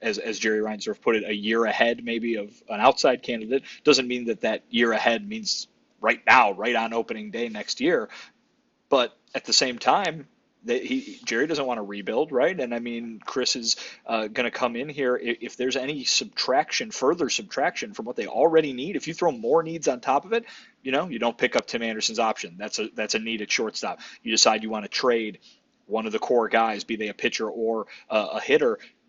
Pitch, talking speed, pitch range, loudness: 120 Hz, 225 wpm, 110-150 Hz, -25 LUFS